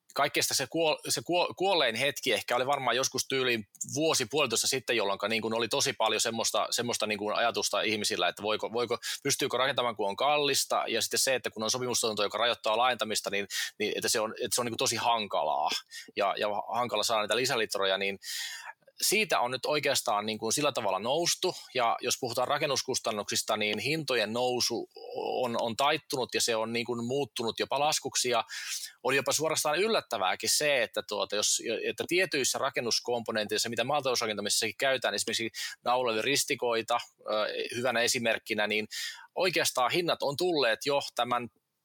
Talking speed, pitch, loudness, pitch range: 160 wpm, 120 Hz, -29 LUFS, 110-145 Hz